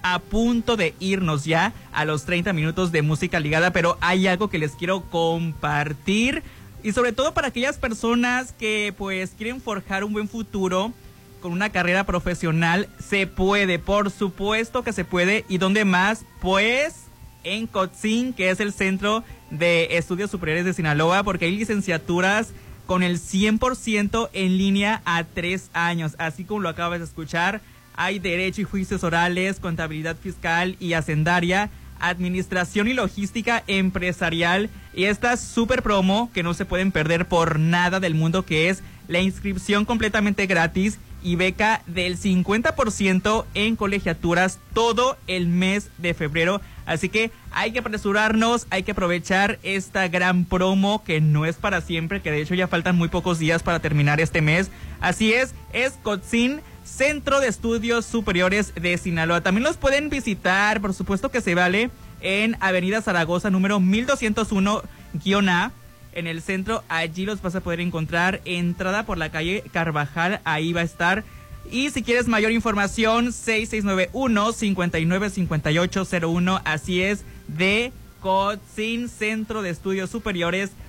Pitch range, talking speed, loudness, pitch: 175-215 Hz, 150 wpm, -22 LUFS, 190 Hz